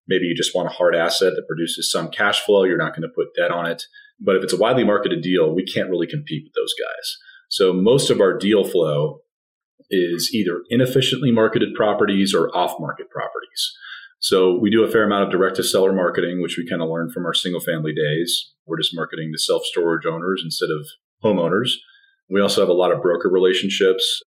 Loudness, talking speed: -19 LUFS, 215 wpm